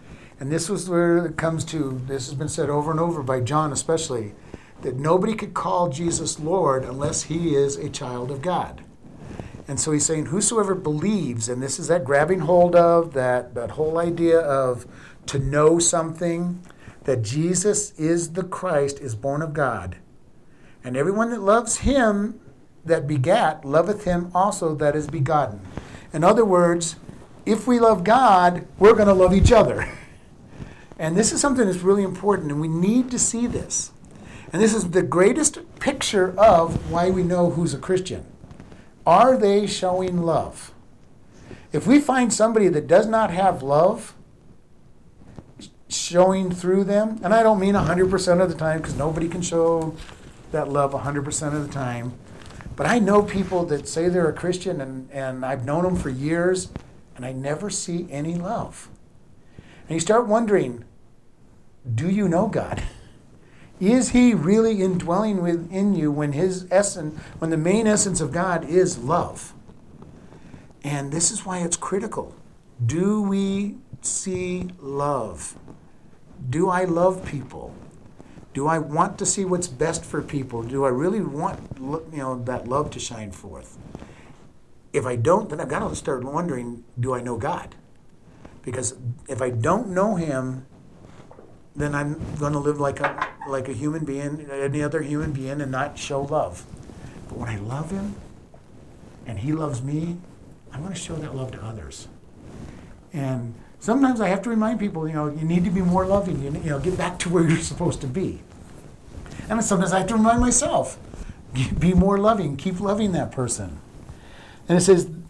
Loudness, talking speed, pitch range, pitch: -22 LUFS, 170 wpm, 140-190 Hz, 165 Hz